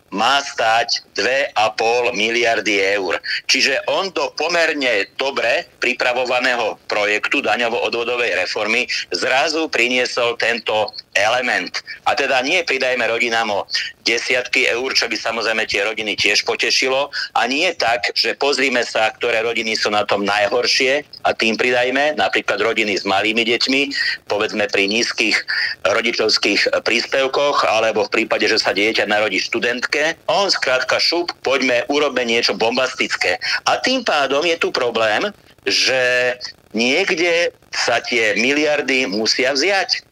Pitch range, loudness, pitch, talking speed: 115-145 Hz, -17 LUFS, 125 Hz, 130 wpm